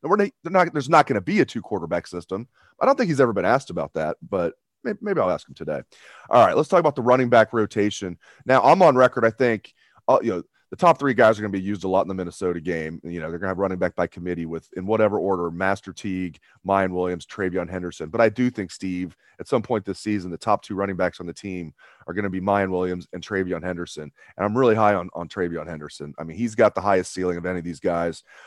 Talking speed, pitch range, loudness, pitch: 270 wpm, 85-105 Hz, -22 LUFS, 95 Hz